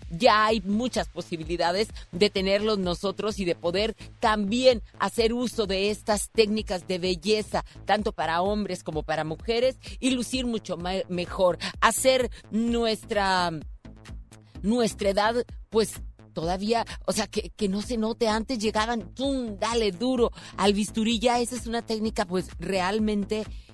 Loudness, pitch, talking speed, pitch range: -26 LUFS, 210 Hz, 140 wpm, 185-225 Hz